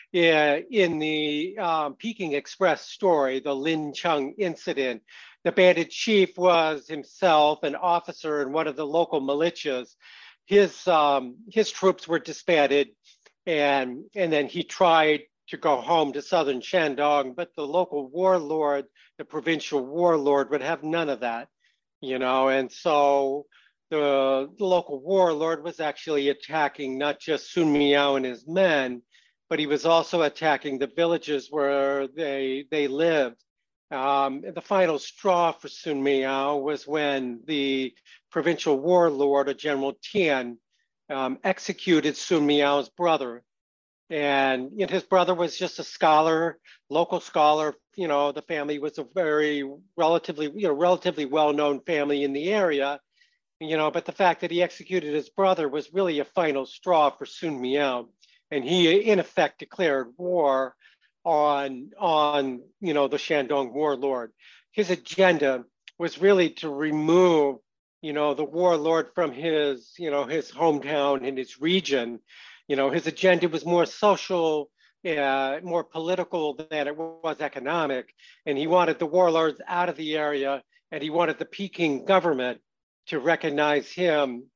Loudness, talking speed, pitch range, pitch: -25 LUFS, 150 wpm, 140-170 Hz, 150 Hz